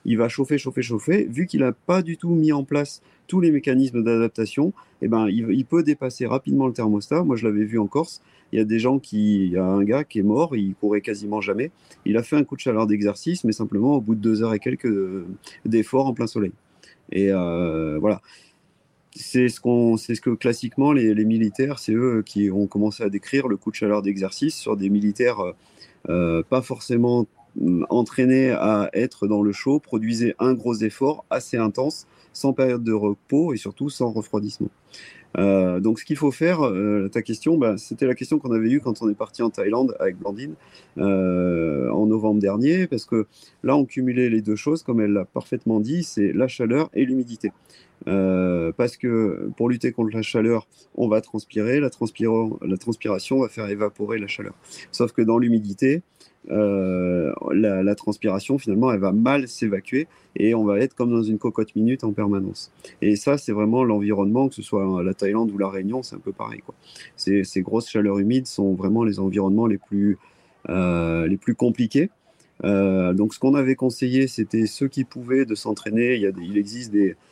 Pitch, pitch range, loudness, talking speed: 110 Hz, 100-130 Hz, -22 LUFS, 205 wpm